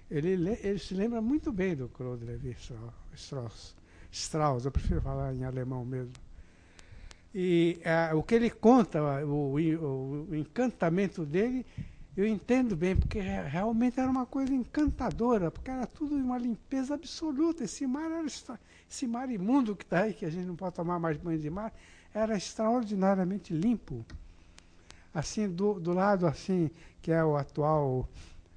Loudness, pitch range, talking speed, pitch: -31 LUFS, 135-230 Hz, 155 wpm, 175 Hz